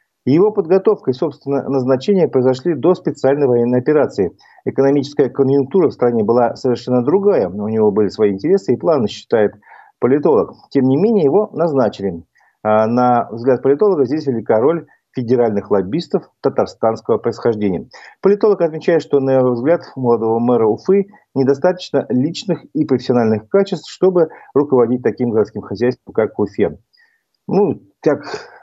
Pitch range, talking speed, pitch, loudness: 120-175 Hz, 140 wpm, 135 Hz, -16 LUFS